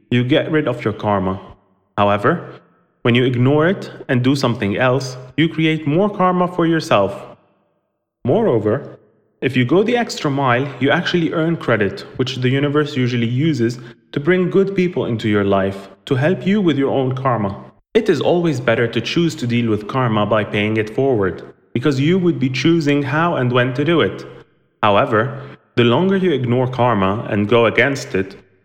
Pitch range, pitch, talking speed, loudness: 115-160 Hz, 130 Hz, 180 wpm, -17 LUFS